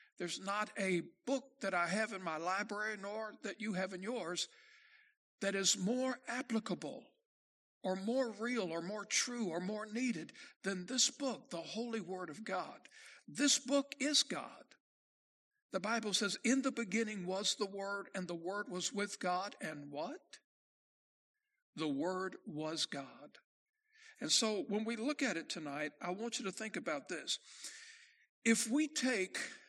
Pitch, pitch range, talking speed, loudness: 215 Hz, 190-260 Hz, 160 wpm, -38 LUFS